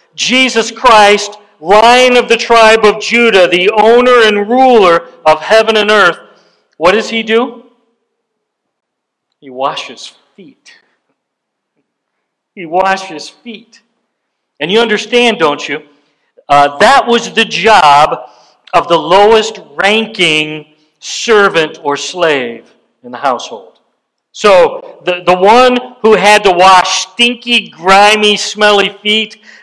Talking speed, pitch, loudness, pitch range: 115 wpm, 210 Hz, -8 LUFS, 175-230 Hz